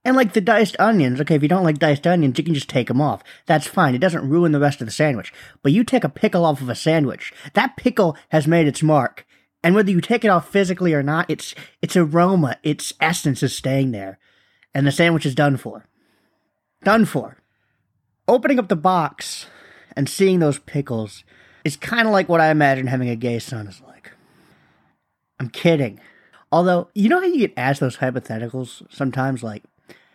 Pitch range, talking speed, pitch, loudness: 130-180 Hz, 205 wpm, 150 Hz, -19 LUFS